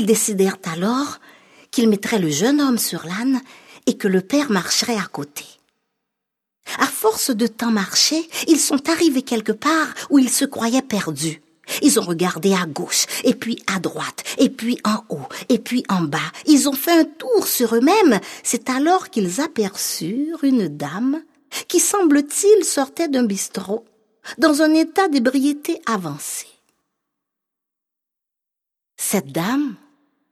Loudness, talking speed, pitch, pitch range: -19 LUFS, 145 wpm, 245 Hz, 210-290 Hz